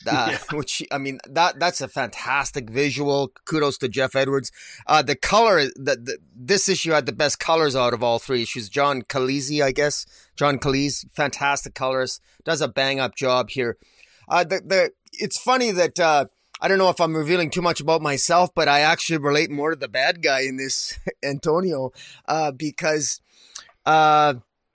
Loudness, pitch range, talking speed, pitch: -21 LUFS, 135-160 Hz, 180 wpm, 145 Hz